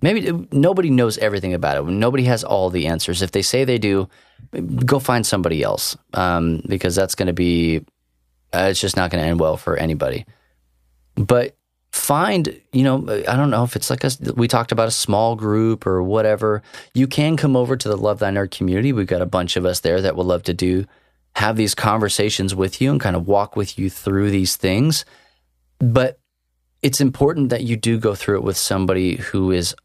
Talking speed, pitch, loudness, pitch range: 200 wpm, 100 Hz, -19 LUFS, 90-120 Hz